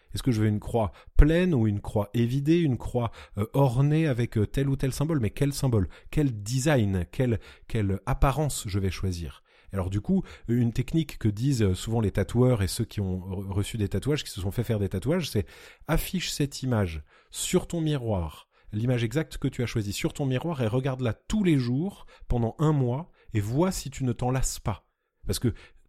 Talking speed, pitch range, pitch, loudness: 210 wpm, 105-145 Hz, 120 Hz, -27 LUFS